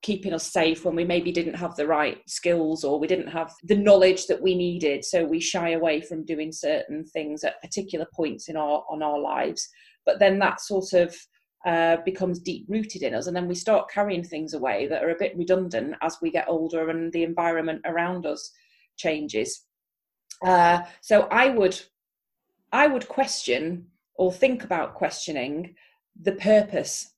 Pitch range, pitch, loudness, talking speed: 165-200 Hz, 175 Hz, -24 LUFS, 180 wpm